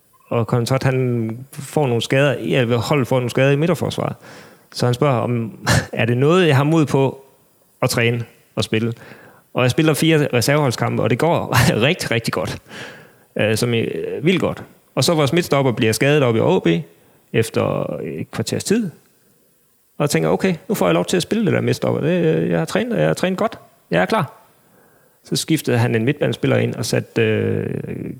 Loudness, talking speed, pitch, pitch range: -18 LUFS, 195 wpm, 125 Hz, 115-145 Hz